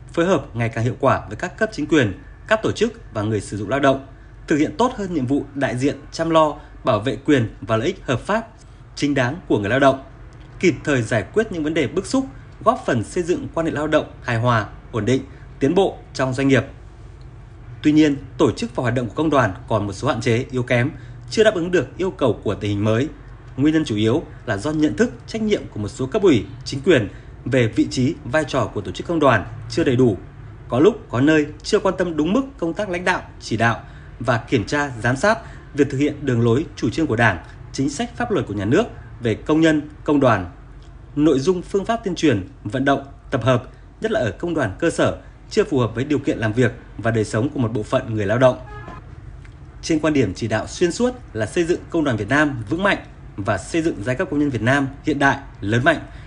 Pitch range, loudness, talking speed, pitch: 115-155 Hz, -20 LUFS, 245 wpm, 130 Hz